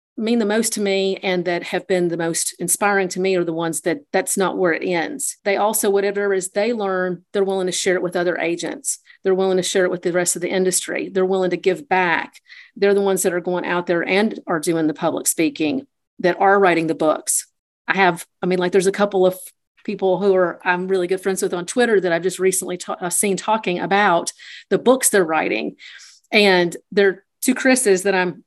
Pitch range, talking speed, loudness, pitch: 175-200 Hz, 230 wpm, -19 LUFS, 185 Hz